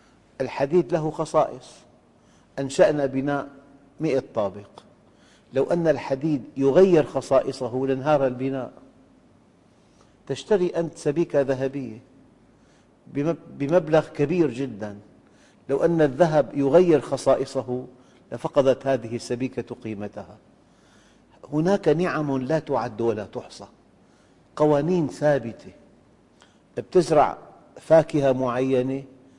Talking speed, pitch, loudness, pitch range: 85 wpm, 135 Hz, -23 LUFS, 130-155 Hz